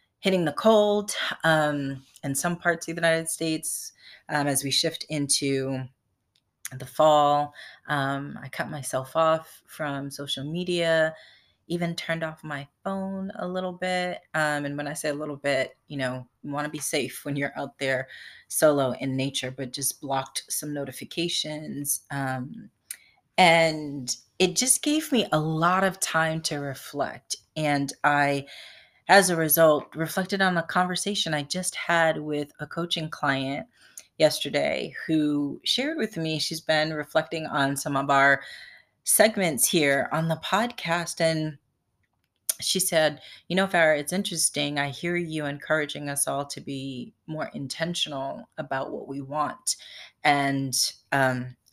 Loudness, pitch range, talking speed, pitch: -25 LUFS, 140-165 Hz, 150 wpm, 150 Hz